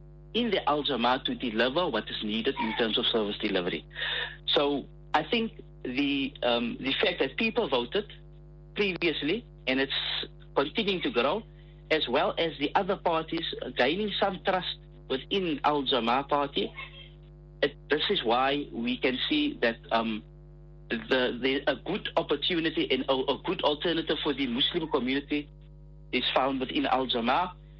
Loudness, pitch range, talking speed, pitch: -28 LUFS, 140-175 Hz, 145 wpm, 160 Hz